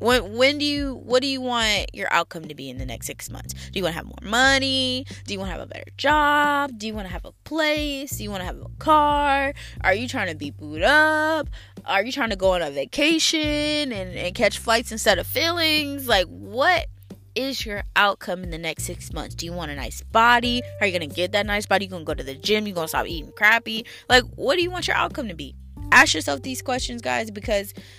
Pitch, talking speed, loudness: 220 Hz, 250 wpm, -22 LUFS